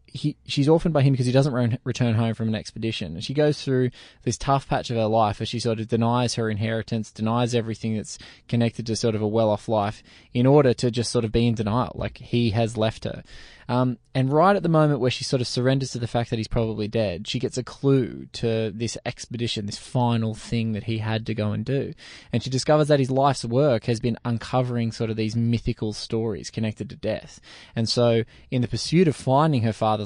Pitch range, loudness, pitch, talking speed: 110-130 Hz, -24 LUFS, 120 Hz, 235 wpm